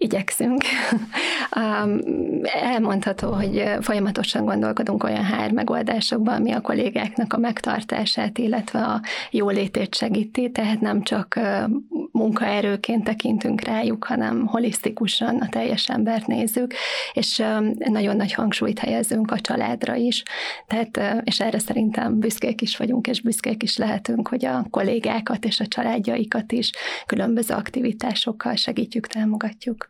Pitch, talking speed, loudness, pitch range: 230 Hz, 120 wpm, -23 LUFS, 220-245 Hz